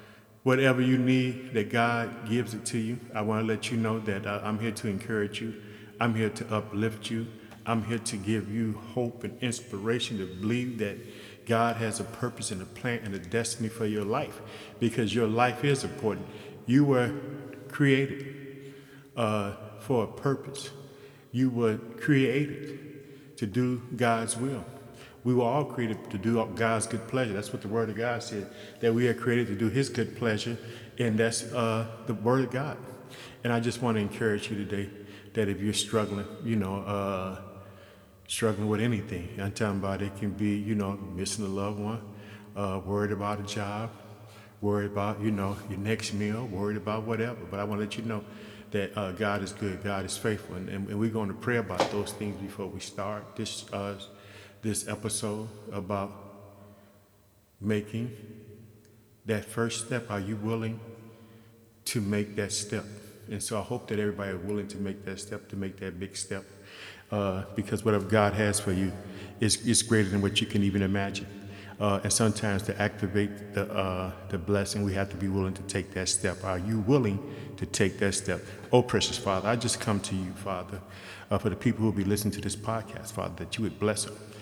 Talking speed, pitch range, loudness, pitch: 195 wpm, 100-115 Hz, -30 LUFS, 105 Hz